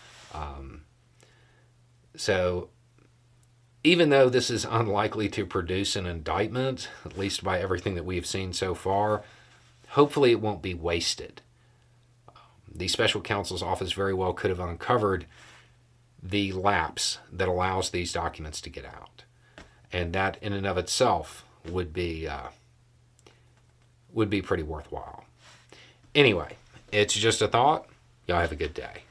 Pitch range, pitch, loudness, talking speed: 90-120 Hz, 105 Hz, -27 LUFS, 135 wpm